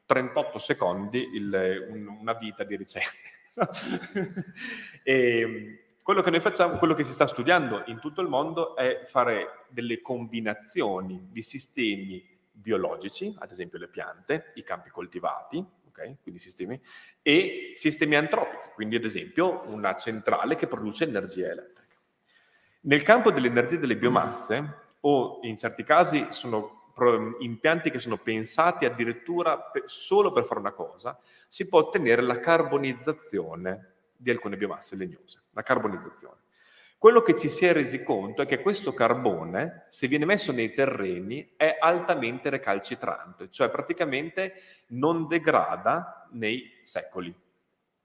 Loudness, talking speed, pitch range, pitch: -26 LUFS, 135 wpm, 115-170 Hz, 130 Hz